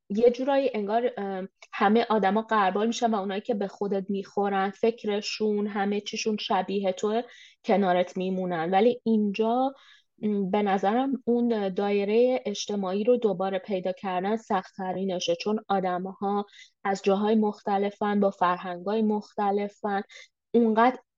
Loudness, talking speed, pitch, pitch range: -26 LUFS, 120 wpm, 205 Hz, 195-225 Hz